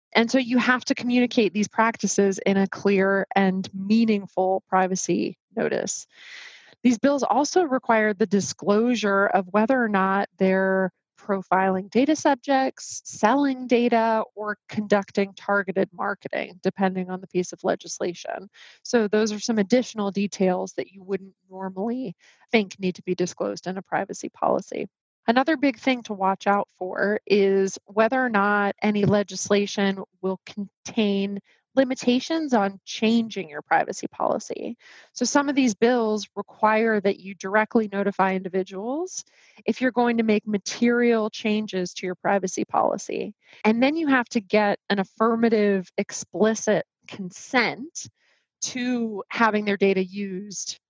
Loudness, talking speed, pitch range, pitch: -23 LUFS, 140 wpm, 190-235 Hz, 205 Hz